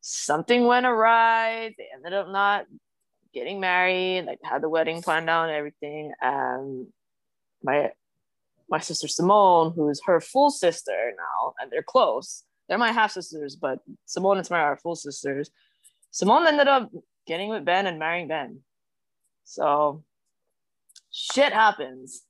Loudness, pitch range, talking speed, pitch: -23 LUFS, 150-220 Hz, 145 wpm, 175 Hz